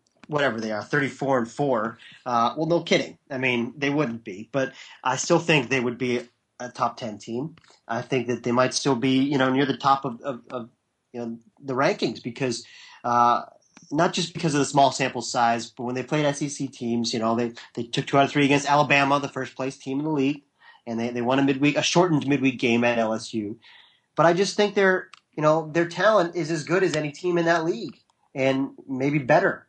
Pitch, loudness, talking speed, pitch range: 135 Hz, -24 LUFS, 225 wpm, 120-150 Hz